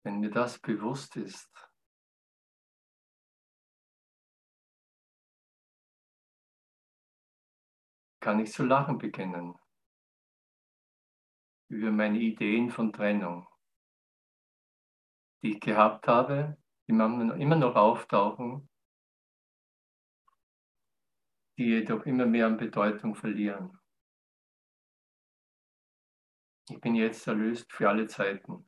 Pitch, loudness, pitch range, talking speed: 110 Hz, -29 LUFS, 105-120 Hz, 75 wpm